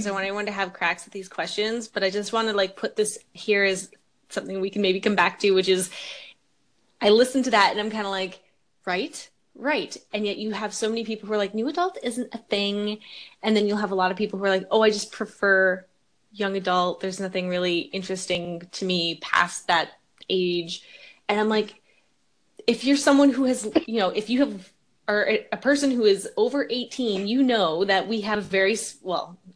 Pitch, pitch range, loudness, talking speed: 205 Hz, 190-220 Hz, -24 LUFS, 220 wpm